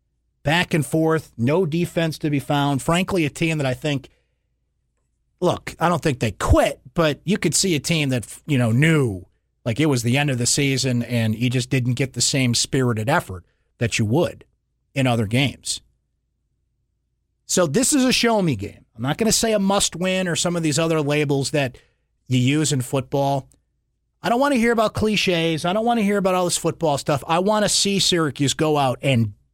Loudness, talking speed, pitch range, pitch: -20 LUFS, 210 wpm, 125-170 Hz, 145 Hz